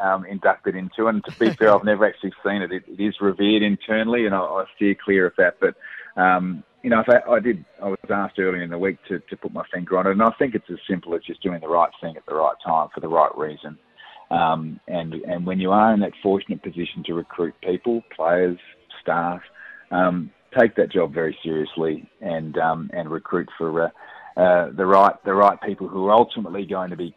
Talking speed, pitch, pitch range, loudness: 230 wpm, 95 Hz, 90-100 Hz, -21 LUFS